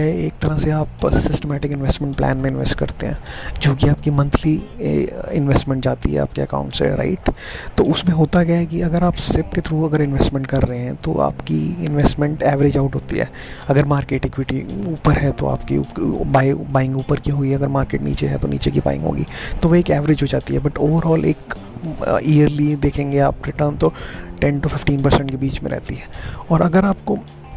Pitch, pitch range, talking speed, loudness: 140 Hz, 125-155 Hz, 200 wpm, -19 LUFS